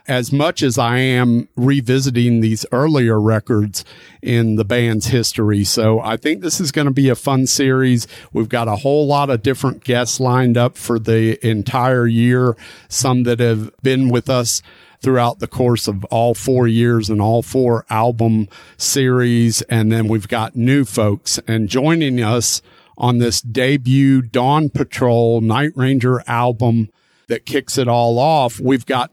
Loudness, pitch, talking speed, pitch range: -16 LUFS, 120 Hz, 165 wpm, 115-130 Hz